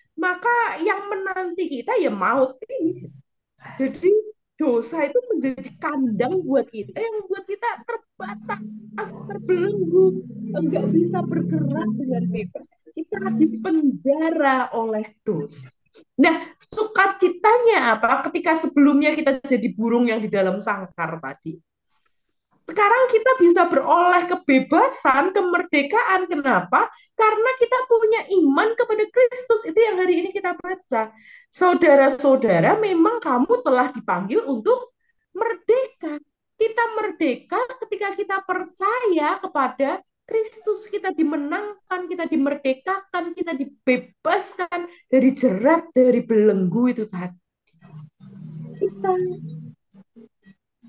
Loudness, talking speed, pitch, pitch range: -21 LUFS, 105 wpm, 315 Hz, 235-395 Hz